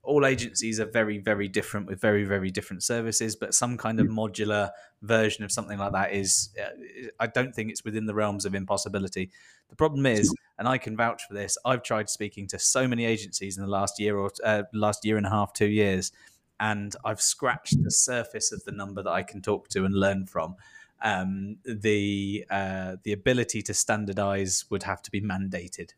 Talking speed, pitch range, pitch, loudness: 205 wpm, 100-110 Hz, 105 Hz, -27 LUFS